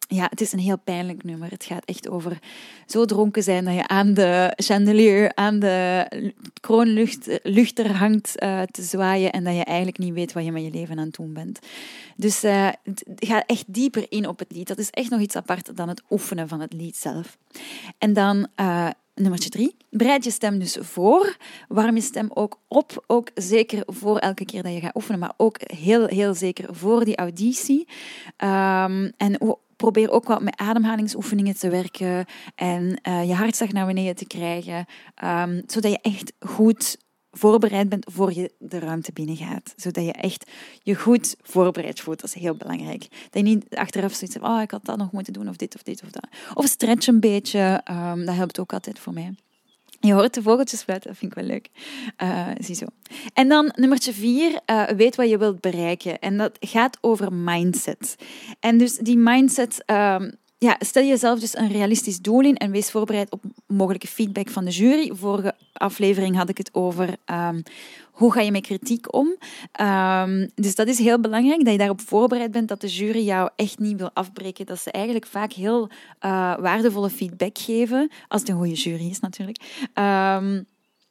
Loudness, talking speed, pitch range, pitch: -22 LUFS, 195 wpm, 185-230 Hz, 205 Hz